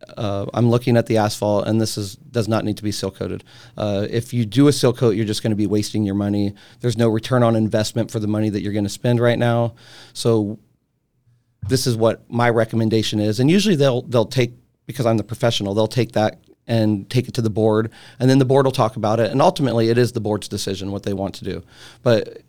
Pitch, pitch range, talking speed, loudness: 115 Hz, 105-120 Hz, 245 wpm, -19 LUFS